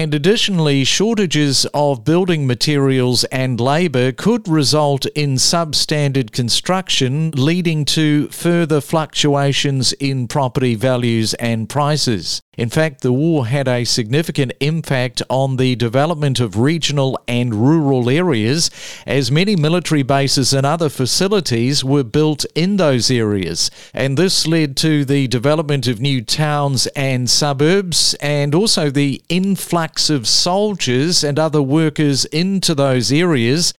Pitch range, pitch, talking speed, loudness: 130-160 Hz, 145 Hz, 130 wpm, -16 LUFS